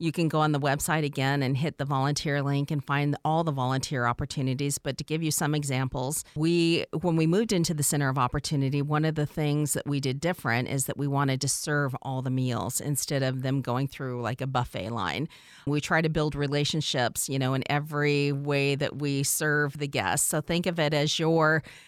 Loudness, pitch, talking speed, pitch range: -27 LUFS, 145 Hz, 220 wpm, 135-155 Hz